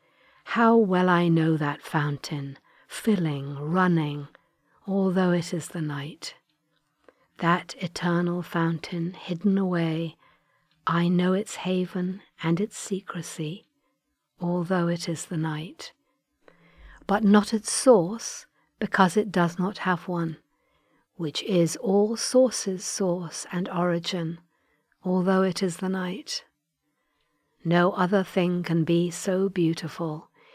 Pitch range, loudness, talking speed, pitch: 165-190 Hz, -26 LUFS, 115 wpm, 175 Hz